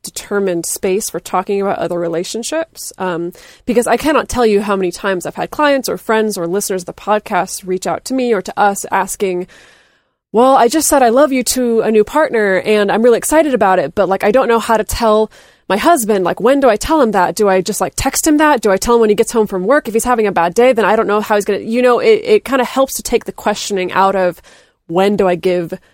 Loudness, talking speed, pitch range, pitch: -14 LUFS, 270 wpm, 190-245 Hz, 215 Hz